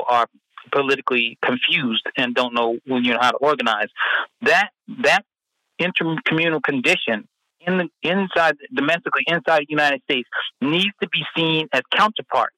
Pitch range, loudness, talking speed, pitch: 125-170 Hz, -20 LUFS, 145 wpm, 150 Hz